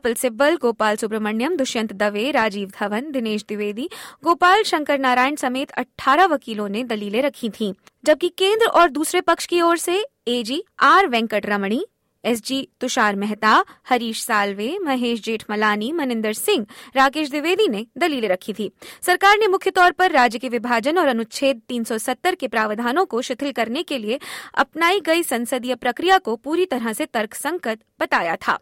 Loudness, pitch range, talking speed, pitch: -20 LUFS, 225-330 Hz, 160 wpm, 255 Hz